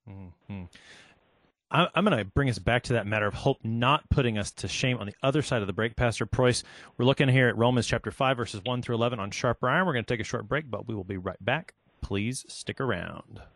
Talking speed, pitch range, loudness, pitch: 250 wpm, 105-130 Hz, -27 LUFS, 120 Hz